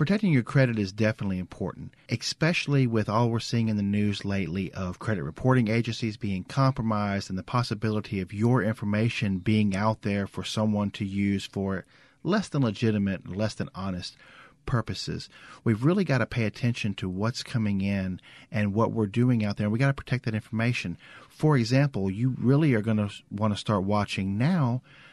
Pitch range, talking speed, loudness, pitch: 100-125 Hz, 180 wpm, -27 LUFS, 110 Hz